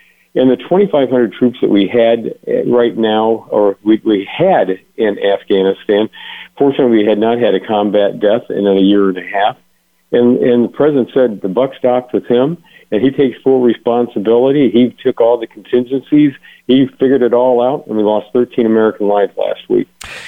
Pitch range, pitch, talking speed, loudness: 105-125 Hz, 120 Hz, 185 wpm, -13 LUFS